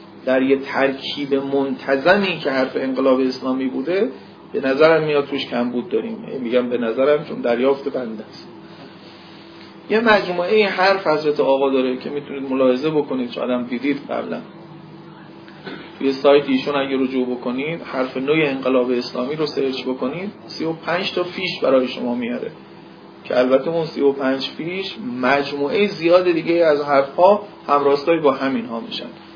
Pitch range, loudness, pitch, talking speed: 130-165 Hz, -19 LUFS, 140 Hz, 150 wpm